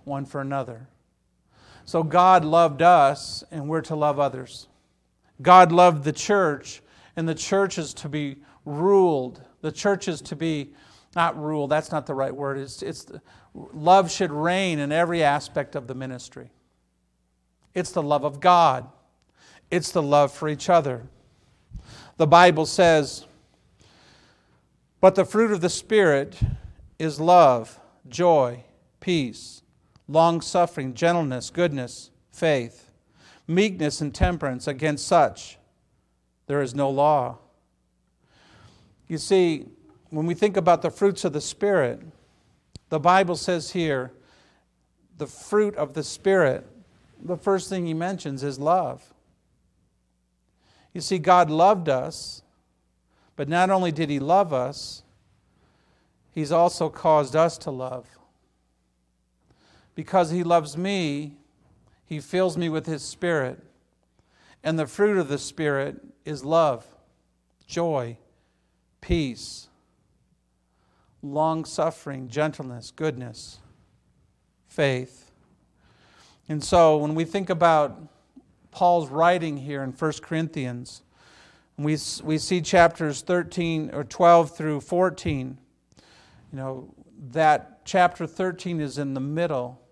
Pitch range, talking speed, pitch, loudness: 130-170 Hz, 120 wpm, 150 Hz, -23 LUFS